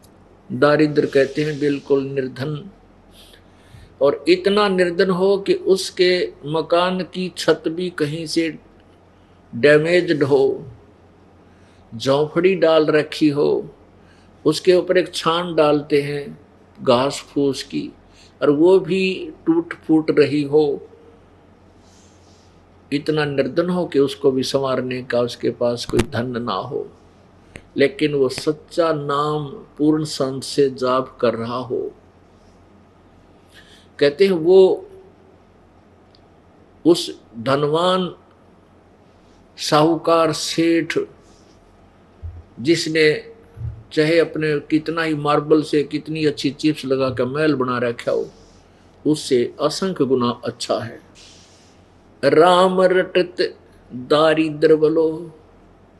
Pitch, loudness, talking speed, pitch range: 145 Hz, -19 LUFS, 105 wpm, 105-165 Hz